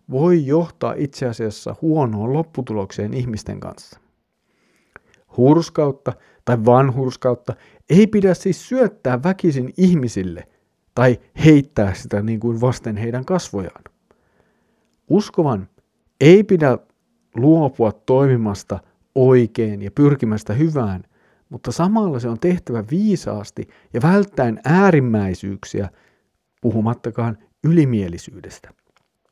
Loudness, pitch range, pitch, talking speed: -18 LUFS, 110-160 Hz, 125 Hz, 90 wpm